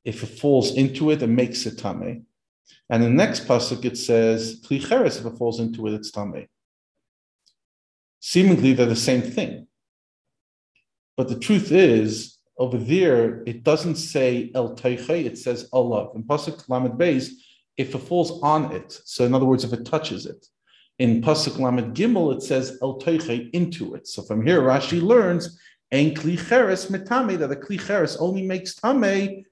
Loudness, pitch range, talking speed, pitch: -22 LUFS, 120-170 Hz, 165 wpm, 130 Hz